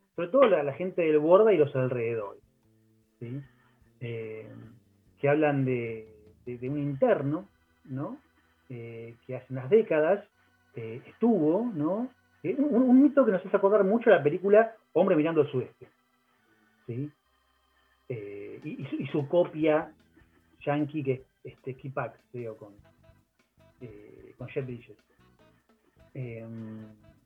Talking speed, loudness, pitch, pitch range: 135 wpm, -27 LUFS, 130 Hz, 110-155 Hz